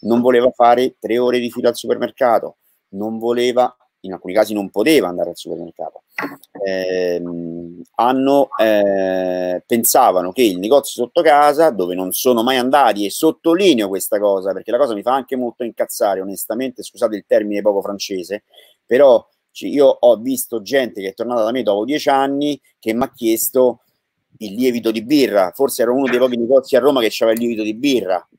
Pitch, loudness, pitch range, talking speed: 120 Hz, -16 LUFS, 100-130 Hz, 185 wpm